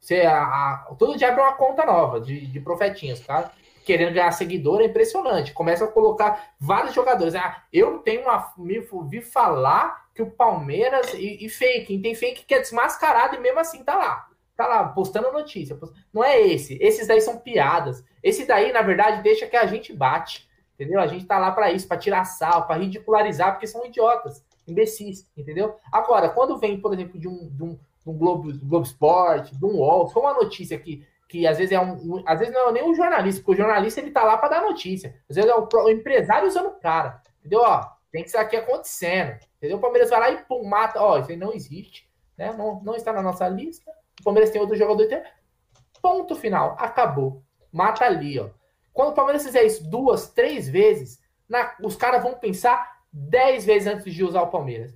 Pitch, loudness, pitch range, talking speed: 210 Hz, -21 LUFS, 175-245 Hz, 215 wpm